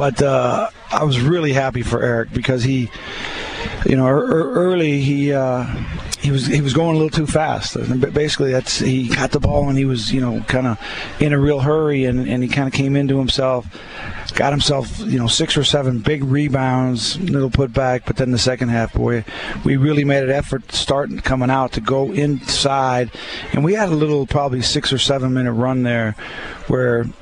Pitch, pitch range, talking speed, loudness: 135 Hz, 125-145 Hz, 200 wpm, -18 LUFS